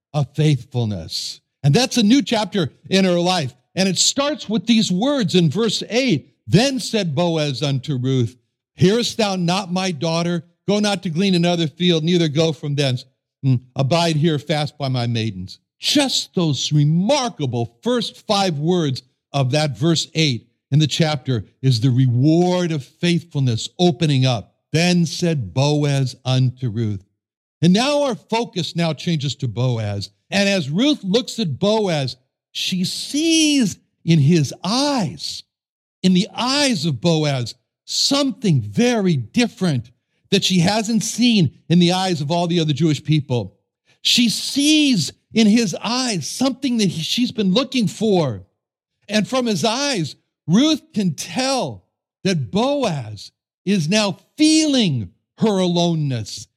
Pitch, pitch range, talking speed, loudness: 170 Hz, 135-210 Hz, 145 wpm, -19 LUFS